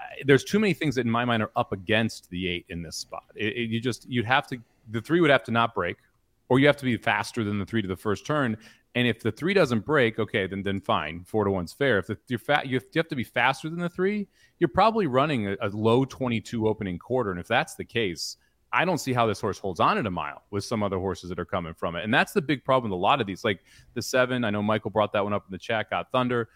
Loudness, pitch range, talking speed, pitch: -26 LUFS, 105-130 Hz, 290 wpm, 115 Hz